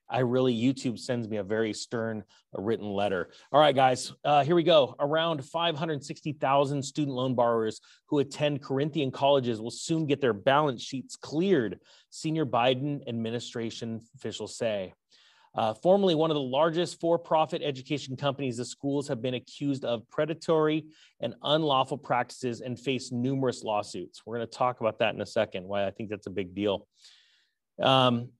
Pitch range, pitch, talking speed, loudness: 115-150 Hz, 130 Hz, 165 wpm, -28 LUFS